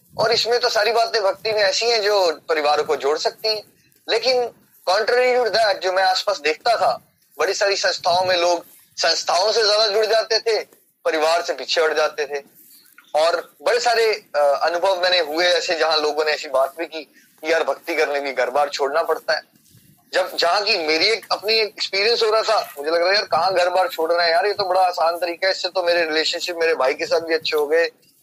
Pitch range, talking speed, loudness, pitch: 160-220 Hz, 215 wpm, -19 LUFS, 185 Hz